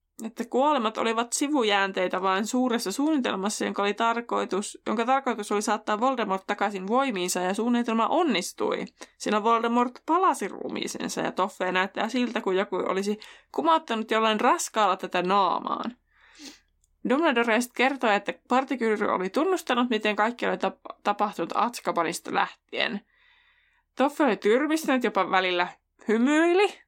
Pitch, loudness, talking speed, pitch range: 230 Hz, -26 LUFS, 125 wpm, 205-265 Hz